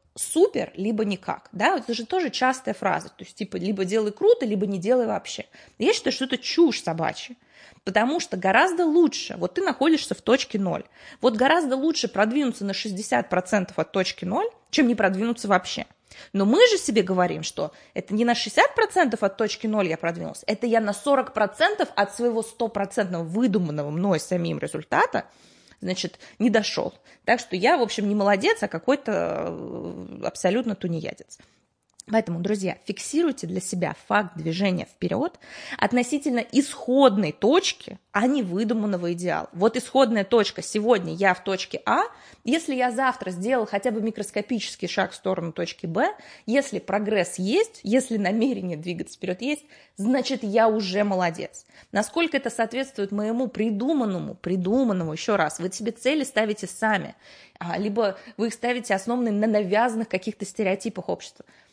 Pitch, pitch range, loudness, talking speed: 220 Hz, 195-255 Hz, -24 LUFS, 155 wpm